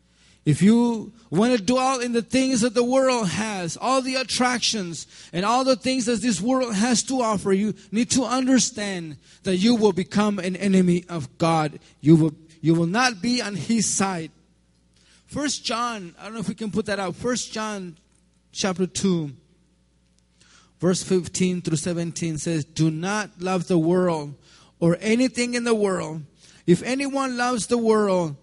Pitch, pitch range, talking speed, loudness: 195 Hz, 165-240 Hz, 170 wpm, -22 LUFS